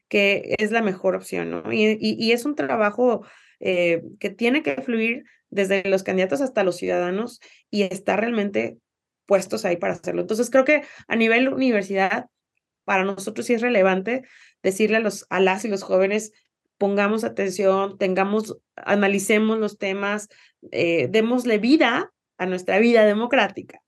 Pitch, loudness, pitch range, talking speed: 205 Hz, -22 LUFS, 195-230 Hz, 155 wpm